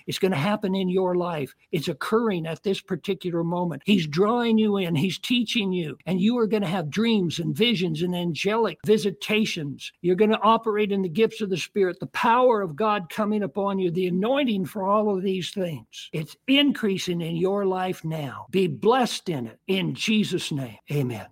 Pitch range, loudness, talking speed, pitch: 175-210 Hz, -24 LUFS, 195 wpm, 190 Hz